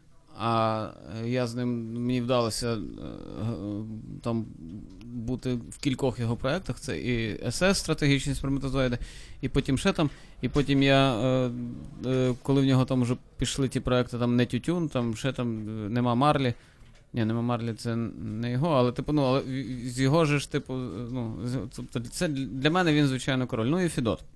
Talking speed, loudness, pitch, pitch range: 160 wpm, -28 LUFS, 125 Hz, 120-135 Hz